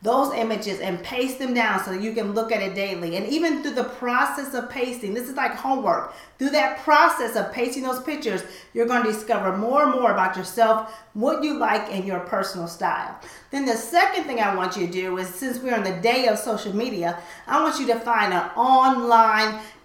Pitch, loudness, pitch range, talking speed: 230 Hz, -22 LUFS, 200-260 Hz, 220 wpm